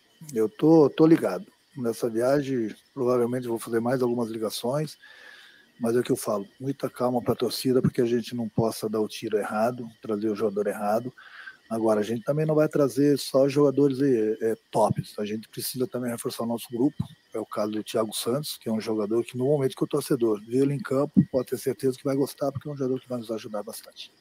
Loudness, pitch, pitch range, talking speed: -26 LUFS, 125 Hz, 115-140 Hz, 225 wpm